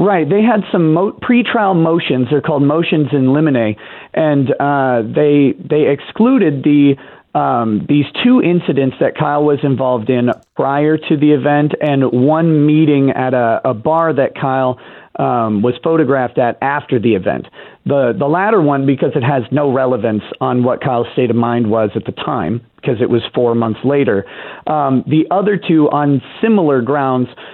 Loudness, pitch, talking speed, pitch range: -14 LUFS, 140 Hz, 170 wpm, 125-155 Hz